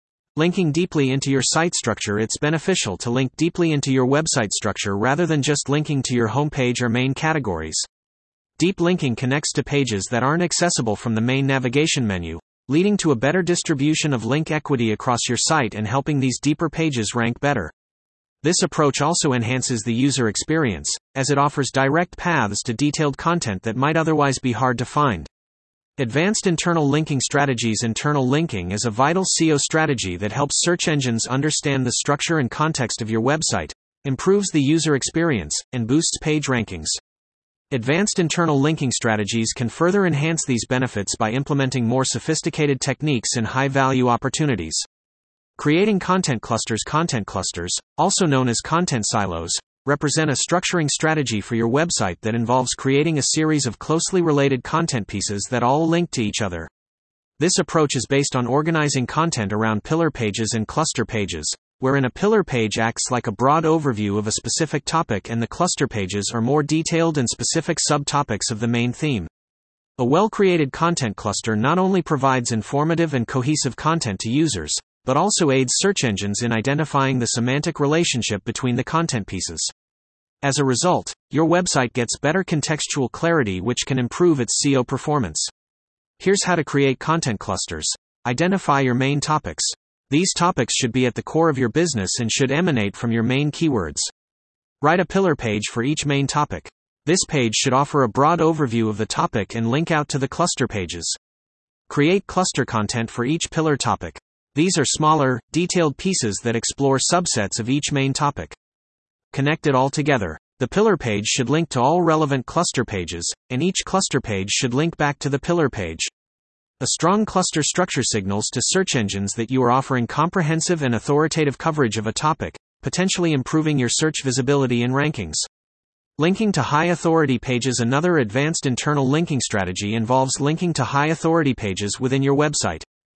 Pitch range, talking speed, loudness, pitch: 115-160 Hz, 175 wpm, -20 LUFS, 135 Hz